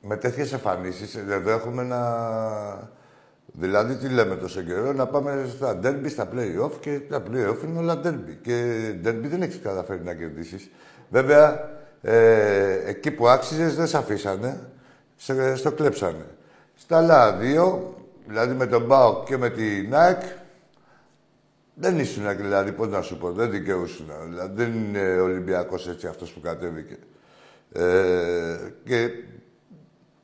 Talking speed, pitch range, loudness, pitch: 140 wpm, 95-140 Hz, -23 LUFS, 115 Hz